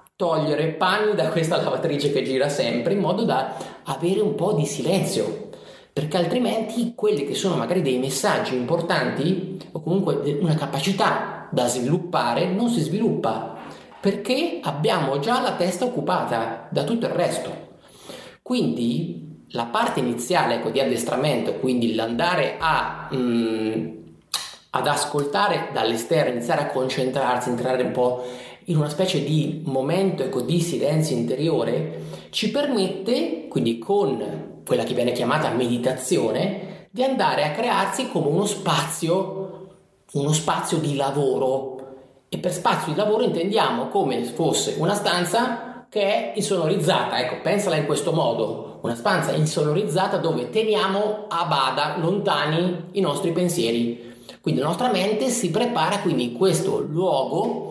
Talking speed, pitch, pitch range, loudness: 135 wpm, 170 Hz, 135-195 Hz, -23 LUFS